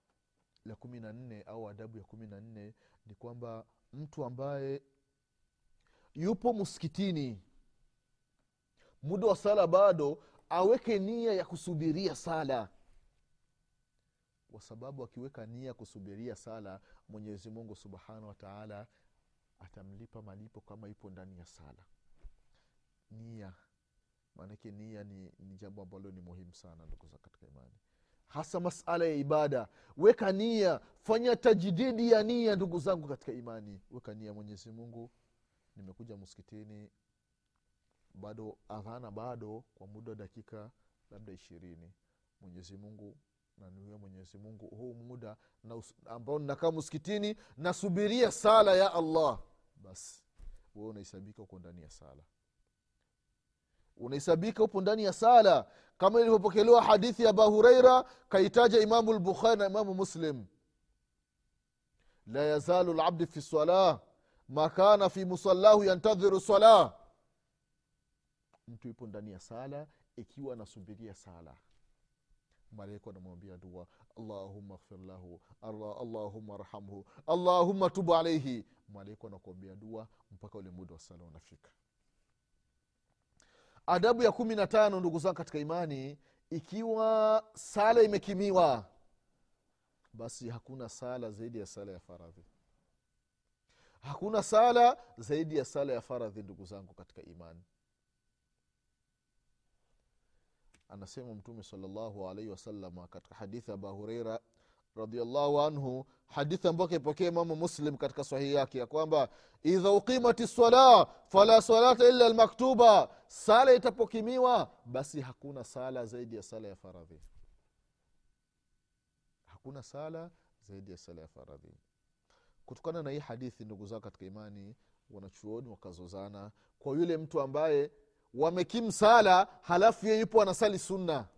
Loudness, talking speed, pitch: -28 LUFS, 100 wpm, 120 Hz